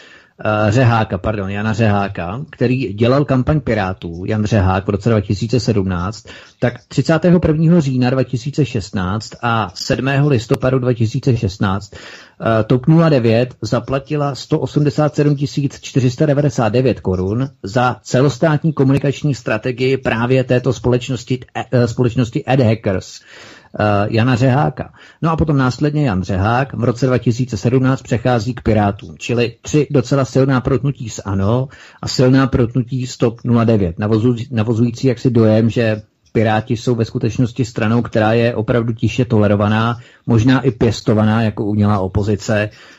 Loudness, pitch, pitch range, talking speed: -16 LUFS, 120 Hz, 110-135 Hz, 115 wpm